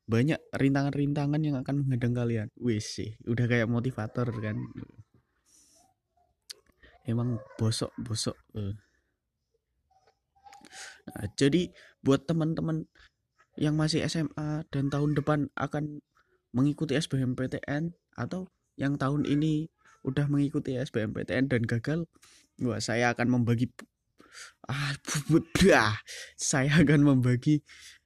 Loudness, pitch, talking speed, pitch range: -29 LUFS, 140 Hz, 100 wpm, 120-150 Hz